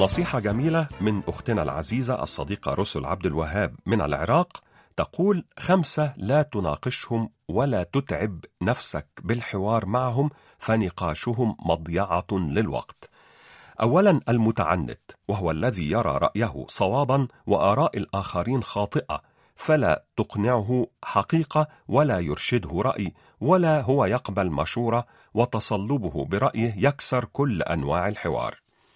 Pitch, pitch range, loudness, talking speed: 115 Hz, 95-135 Hz, -25 LUFS, 100 wpm